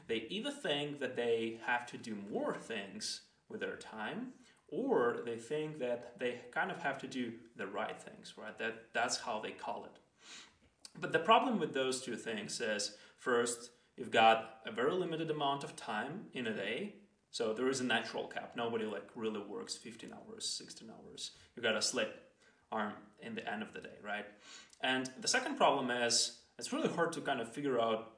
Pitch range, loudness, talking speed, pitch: 115-155 Hz, -37 LUFS, 195 wpm, 125 Hz